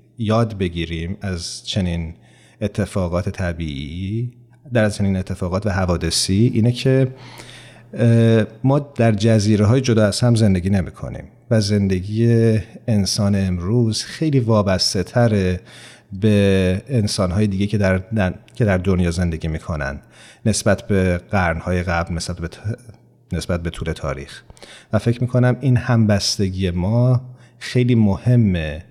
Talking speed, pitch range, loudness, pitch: 130 wpm, 90-115 Hz, -19 LUFS, 105 Hz